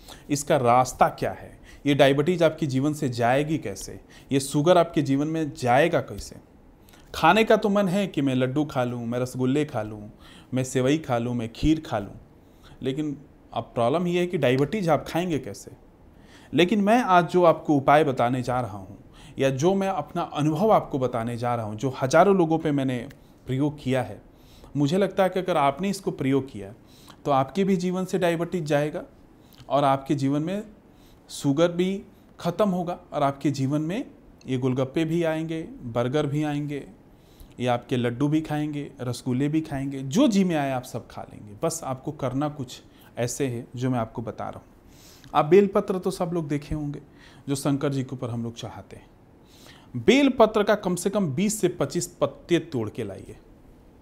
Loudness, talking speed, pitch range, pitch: -24 LUFS, 190 wpm, 125-170 Hz, 145 Hz